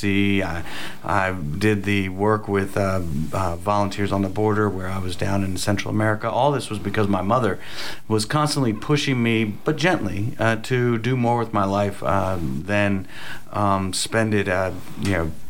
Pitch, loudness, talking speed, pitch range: 100 Hz, -22 LUFS, 180 wpm, 95-110 Hz